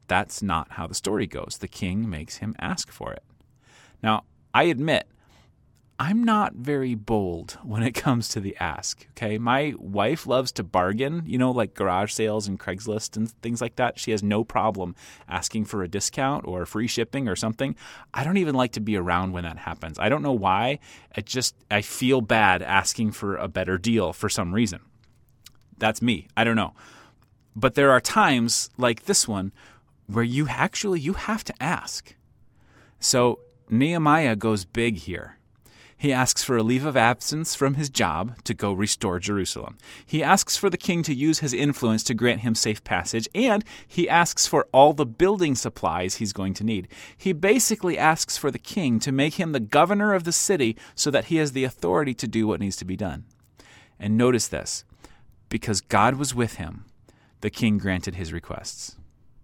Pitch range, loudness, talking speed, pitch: 105-135 Hz, -24 LUFS, 190 wpm, 115 Hz